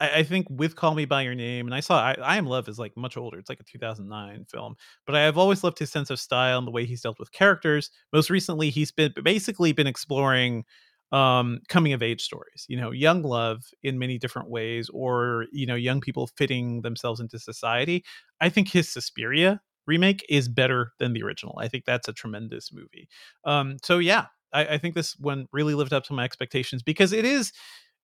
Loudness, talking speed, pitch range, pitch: -25 LUFS, 215 wpm, 120-160 Hz, 135 Hz